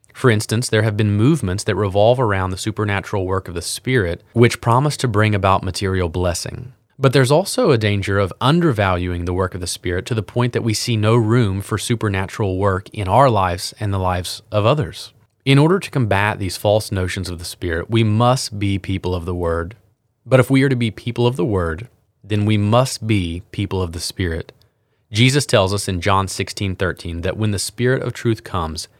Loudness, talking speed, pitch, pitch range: -18 LUFS, 210 wpm, 105 Hz, 95-120 Hz